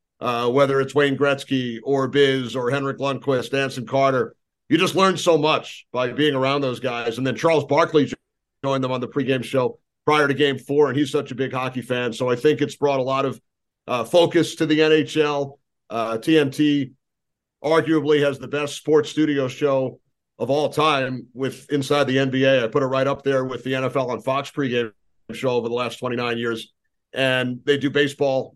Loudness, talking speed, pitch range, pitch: -21 LUFS, 200 wpm, 130-145 Hz, 135 Hz